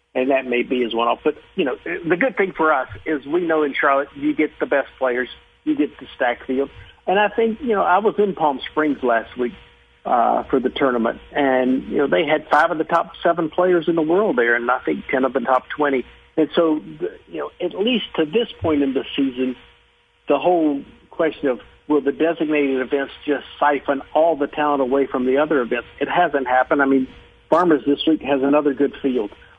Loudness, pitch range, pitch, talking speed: -20 LUFS, 135-165 Hz, 145 Hz, 225 wpm